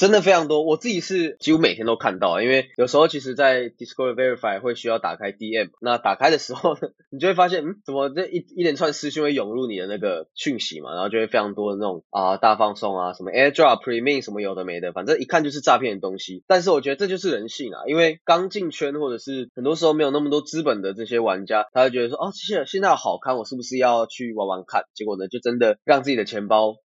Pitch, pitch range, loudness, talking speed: 130 Hz, 115-155 Hz, -22 LUFS, 430 characters per minute